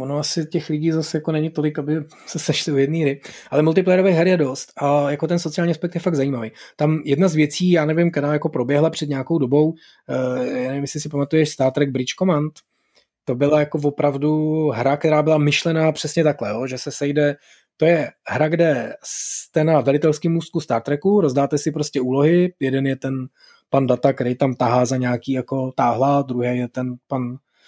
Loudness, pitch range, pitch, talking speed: -20 LUFS, 135-160 Hz, 150 Hz, 200 wpm